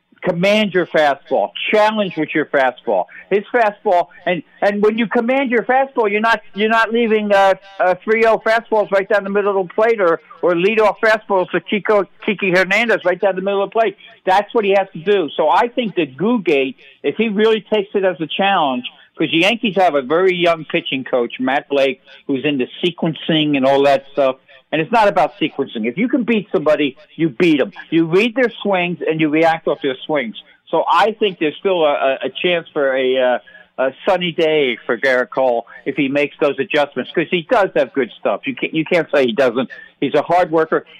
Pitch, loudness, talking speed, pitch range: 180 Hz, -16 LUFS, 215 wpm, 150-215 Hz